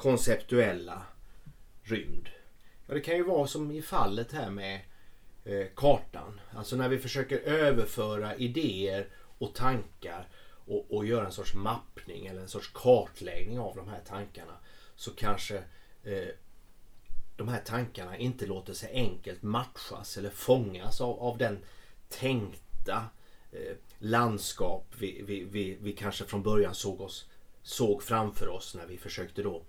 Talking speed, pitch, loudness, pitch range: 145 wpm, 100 Hz, -33 LUFS, 95-120 Hz